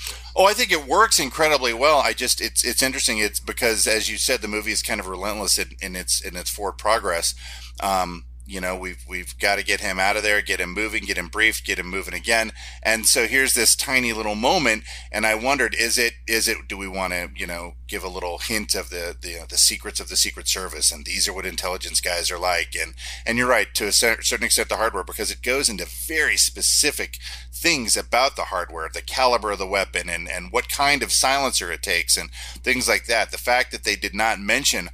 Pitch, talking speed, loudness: 95 Hz, 235 wpm, -21 LUFS